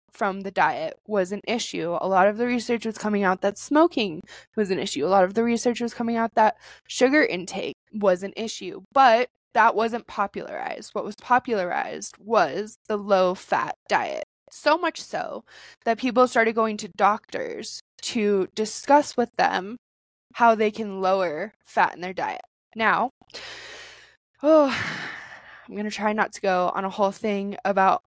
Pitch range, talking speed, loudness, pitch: 195-235 Hz, 170 wpm, -24 LUFS, 215 Hz